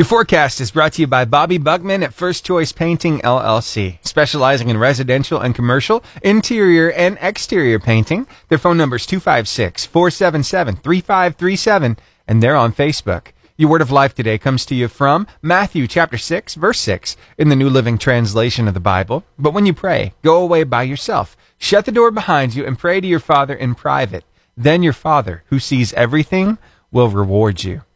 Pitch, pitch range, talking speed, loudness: 145 Hz, 120-175 Hz, 180 wpm, -15 LUFS